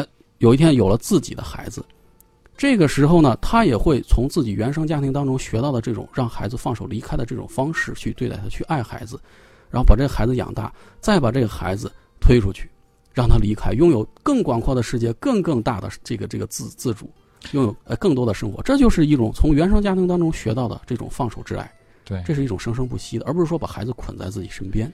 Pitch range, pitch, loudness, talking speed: 110-140 Hz, 120 Hz, -21 LUFS, 350 characters per minute